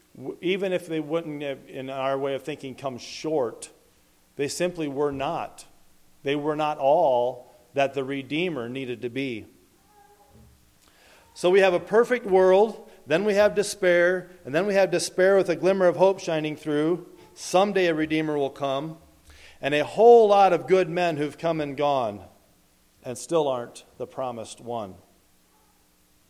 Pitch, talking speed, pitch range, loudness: 155 Hz, 155 wpm, 135-185 Hz, -24 LUFS